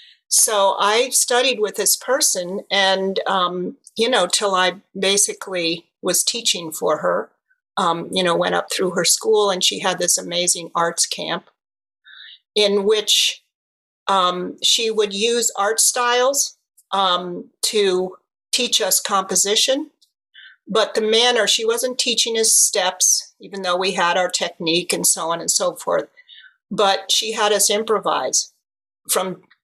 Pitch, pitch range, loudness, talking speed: 200 Hz, 180-230 Hz, -18 LUFS, 145 wpm